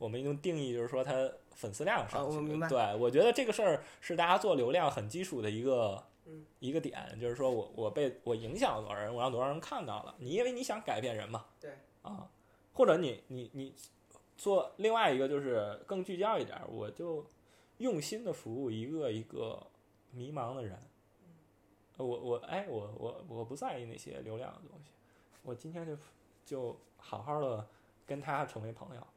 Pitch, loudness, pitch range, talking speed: 135 Hz, -36 LUFS, 115-160 Hz, 270 characters per minute